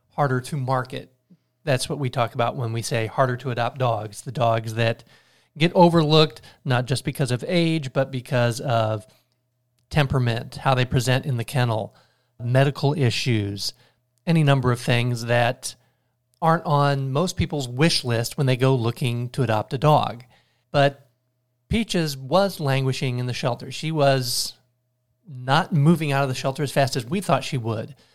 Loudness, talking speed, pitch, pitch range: -22 LUFS, 165 wpm, 130 Hz, 125-145 Hz